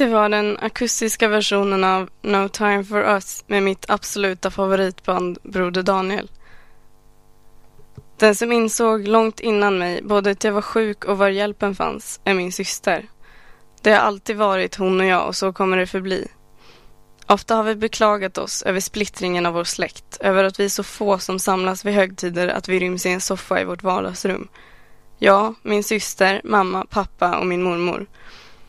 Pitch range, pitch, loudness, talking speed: 185-210 Hz, 195 Hz, -20 LUFS, 175 wpm